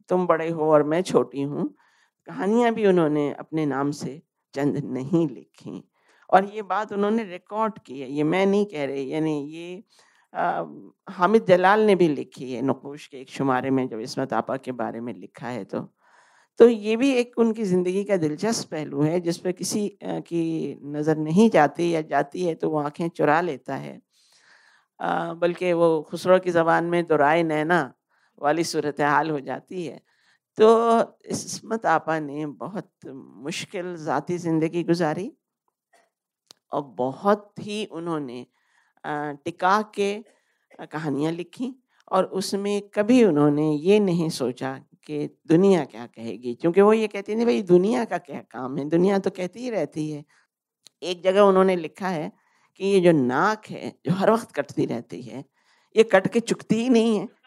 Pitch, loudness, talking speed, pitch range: 170 Hz, -23 LUFS, 165 wpm, 150-200 Hz